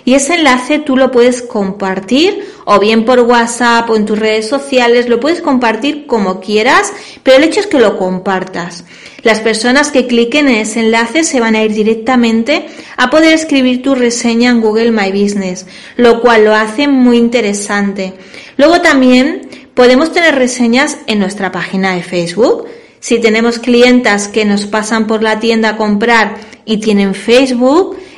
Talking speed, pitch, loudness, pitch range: 170 wpm, 235 Hz, -10 LUFS, 215-265 Hz